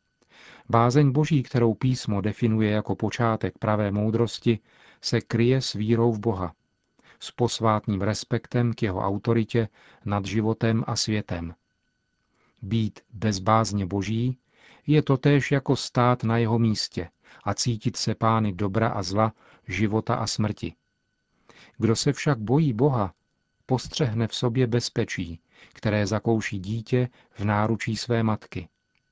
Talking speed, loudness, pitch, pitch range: 125 wpm, -25 LUFS, 115 Hz, 105-120 Hz